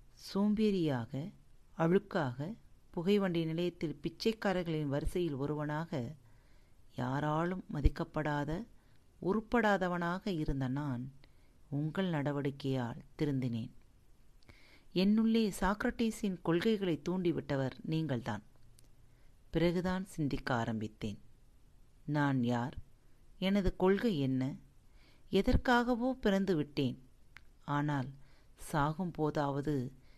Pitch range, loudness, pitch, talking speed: 130-185 Hz, -35 LUFS, 150 Hz, 65 wpm